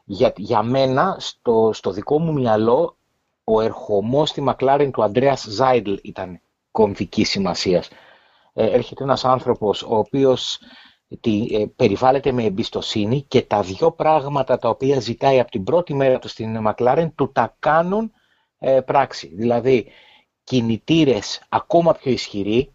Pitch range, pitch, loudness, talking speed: 110-140 Hz, 130 Hz, -19 LUFS, 140 wpm